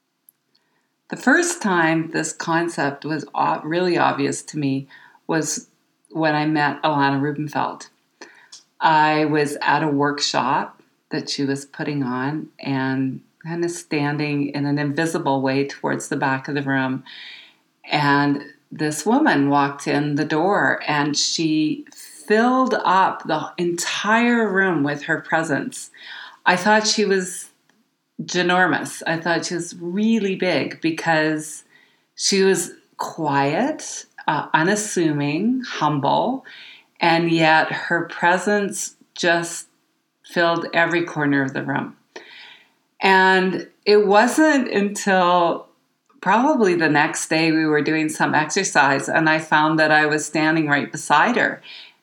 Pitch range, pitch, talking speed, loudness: 145-190 Hz, 160 Hz, 125 wpm, -20 LUFS